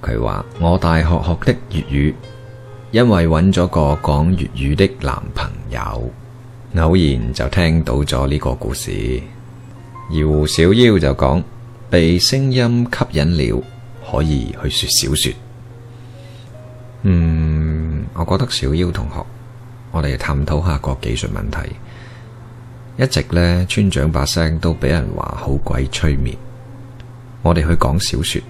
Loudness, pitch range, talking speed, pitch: -17 LUFS, 75-120 Hz, 185 characters per minute, 90 Hz